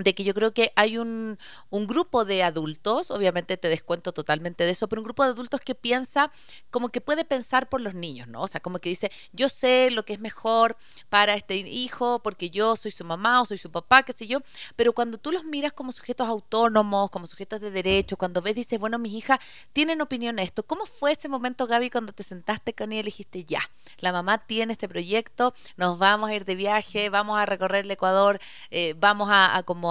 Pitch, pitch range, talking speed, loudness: 215 Hz, 190-245 Hz, 230 wpm, -25 LUFS